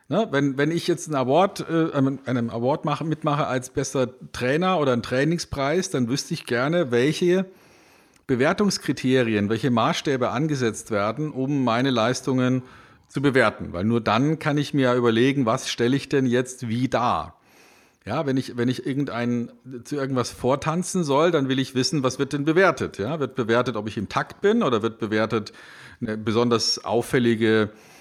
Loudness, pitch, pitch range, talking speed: -23 LUFS, 130 Hz, 120-150 Hz, 165 wpm